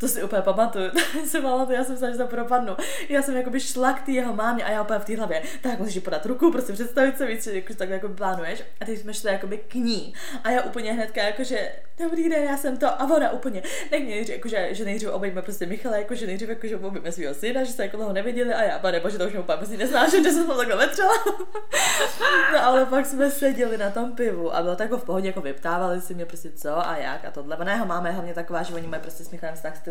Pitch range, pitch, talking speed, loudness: 190-260 Hz, 225 Hz, 260 wpm, -25 LUFS